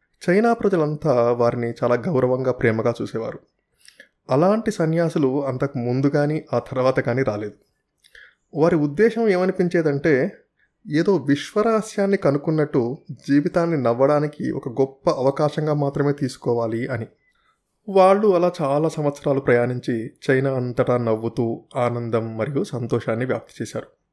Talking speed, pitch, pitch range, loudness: 105 wpm, 140 Hz, 120-165 Hz, -21 LUFS